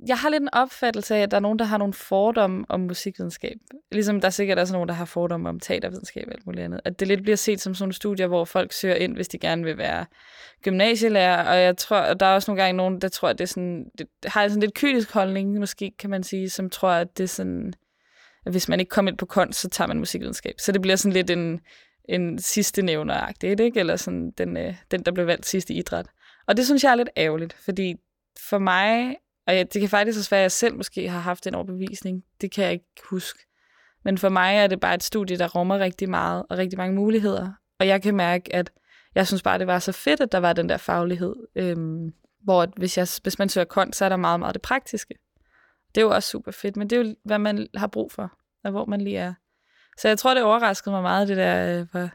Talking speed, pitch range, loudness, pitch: 255 wpm, 180-205 Hz, -23 LUFS, 190 Hz